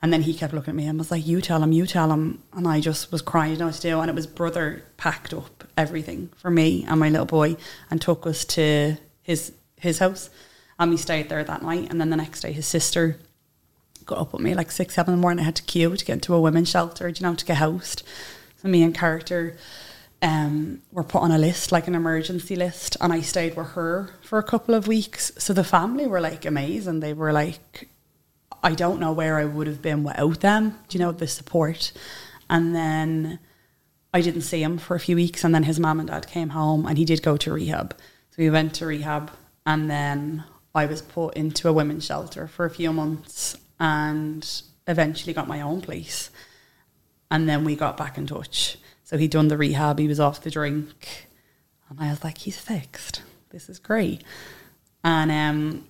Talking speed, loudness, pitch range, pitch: 220 wpm, -24 LUFS, 155-170 Hz, 160 Hz